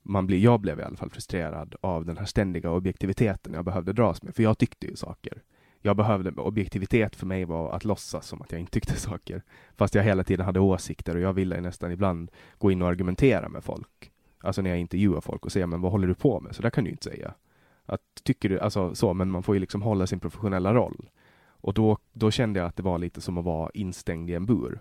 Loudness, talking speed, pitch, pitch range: -27 LUFS, 250 wpm, 95 Hz, 90-105 Hz